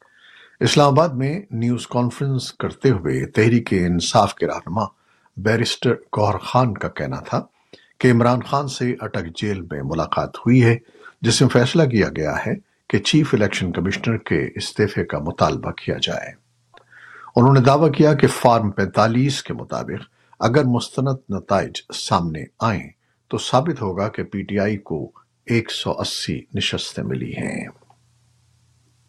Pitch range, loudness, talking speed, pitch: 100-130 Hz, -20 LUFS, 145 wpm, 115 Hz